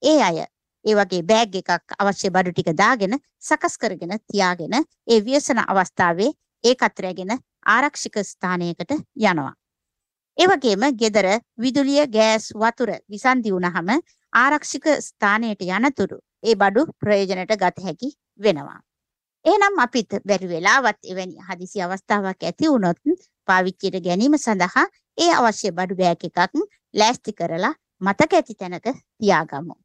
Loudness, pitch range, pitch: -20 LUFS, 185-260 Hz, 210 Hz